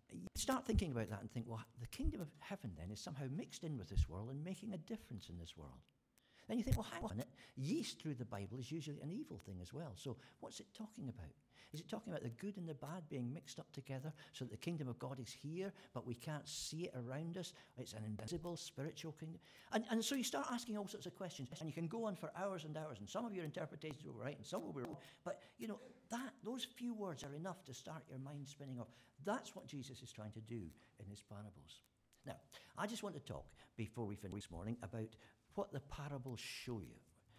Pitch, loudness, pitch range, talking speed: 145 Hz, -48 LUFS, 115-180 Hz, 250 wpm